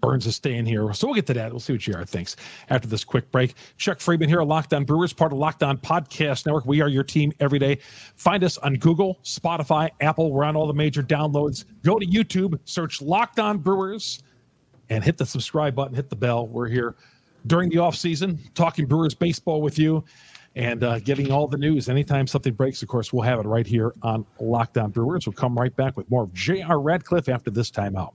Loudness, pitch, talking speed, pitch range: -23 LUFS, 140 Hz, 220 wpm, 125-160 Hz